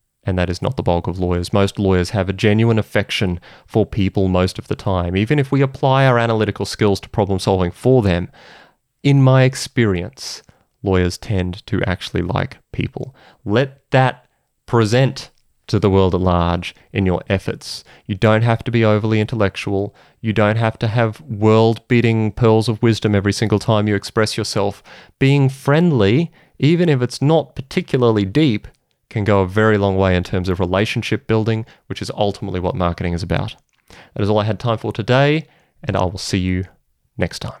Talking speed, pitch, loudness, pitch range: 185 wpm, 105 Hz, -18 LUFS, 95-120 Hz